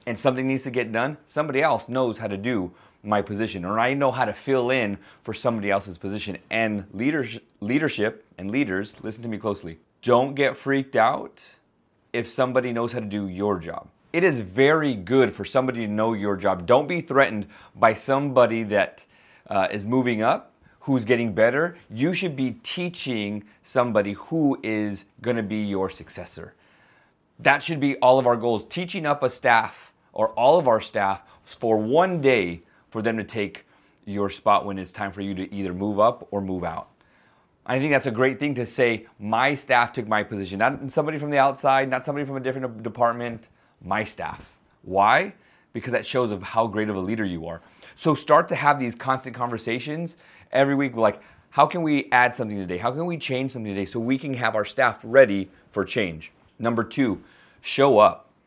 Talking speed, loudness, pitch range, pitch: 195 wpm, -23 LUFS, 105-135 Hz, 115 Hz